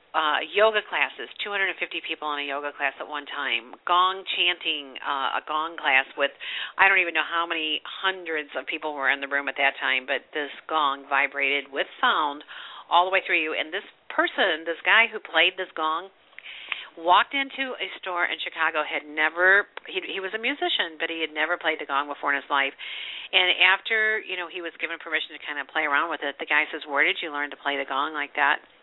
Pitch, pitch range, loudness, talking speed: 160 Hz, 145-185 Hz, -24 LUFS, 225 wpm